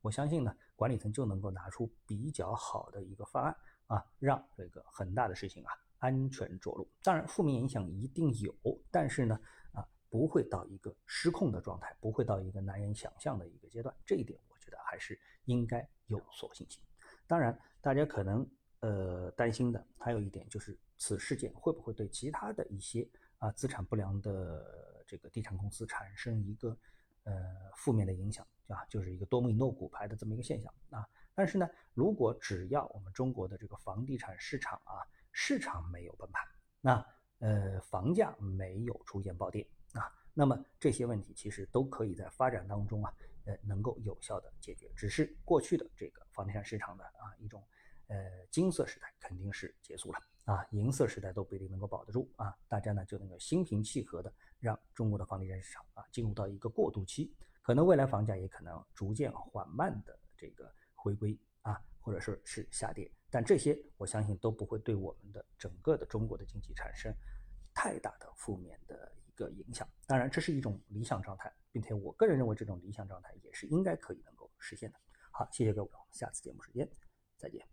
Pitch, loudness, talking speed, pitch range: 105 Hz, -38 LUFS, 305 characters per minute, 95-120 Hz